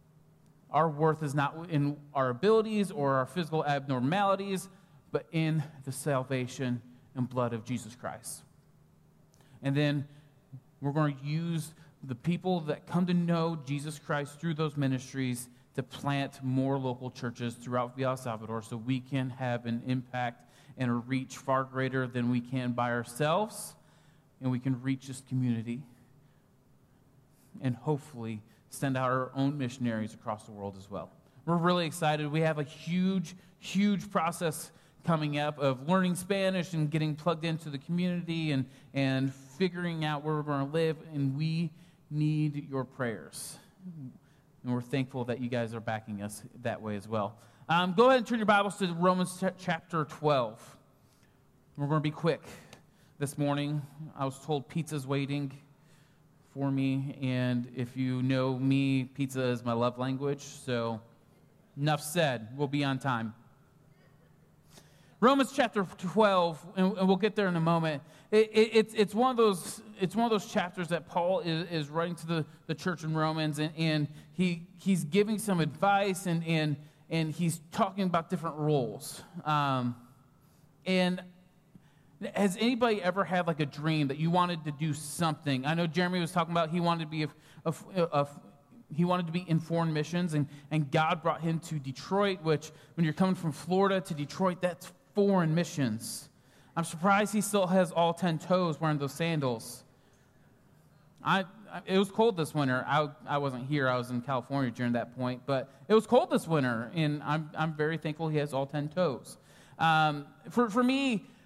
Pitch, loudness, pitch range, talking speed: 150 Hz, -31 LUFS, 135-175 Hz, 175 wpm